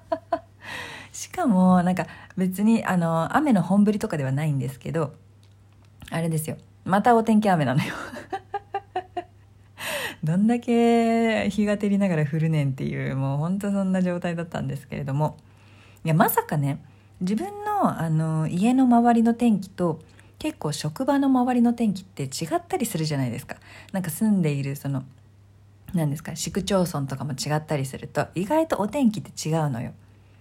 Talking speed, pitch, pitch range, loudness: 320 characters per minute, 170 Hz, 140-220 Hz, -24 LUFS